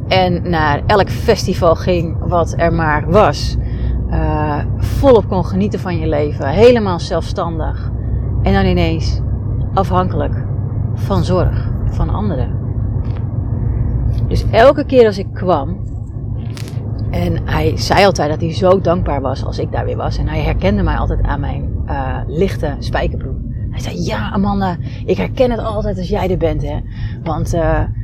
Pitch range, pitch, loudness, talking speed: 100-115 Hz, 110 Hz, -16 LUFS, 150 wpm